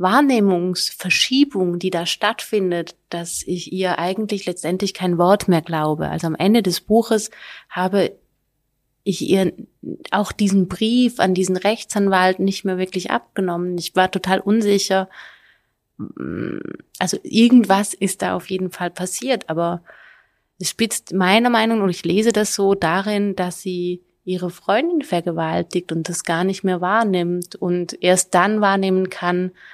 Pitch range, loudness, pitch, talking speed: 180-205 Hz, -19 LUFS, 185 Hz, 140 wpm